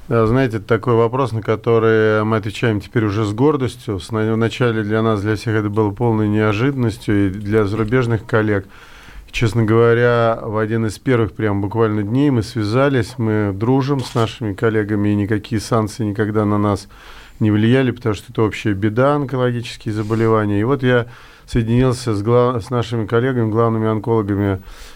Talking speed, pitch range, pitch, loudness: 160 wpm, 105-120 Hz, 110 Hz, -17 LUFS